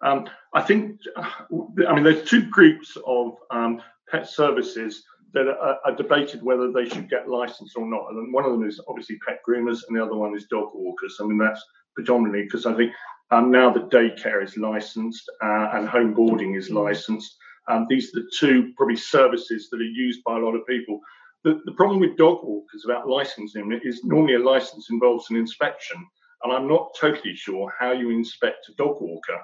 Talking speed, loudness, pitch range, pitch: 200 wpm, -22 LUFS, 110-140 Hz, 120 Hz